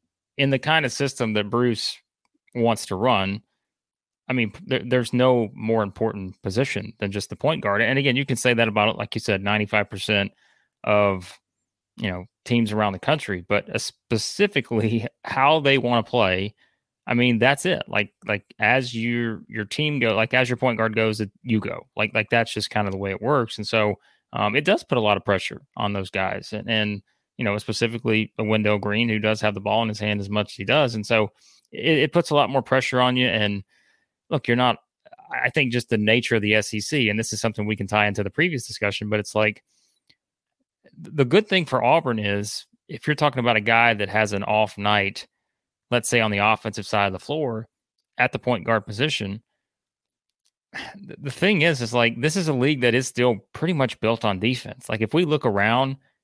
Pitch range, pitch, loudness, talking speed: 105-125 Hz, 115 Hz, -22 LUFS, 215 wpm